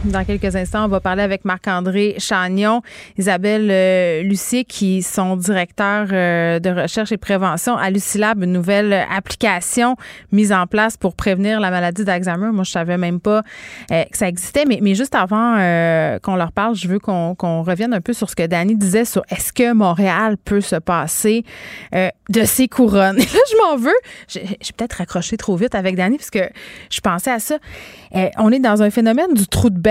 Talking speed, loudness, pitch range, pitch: 205 wpm, -17 LUFS, 185-220 Hz, 200 Hz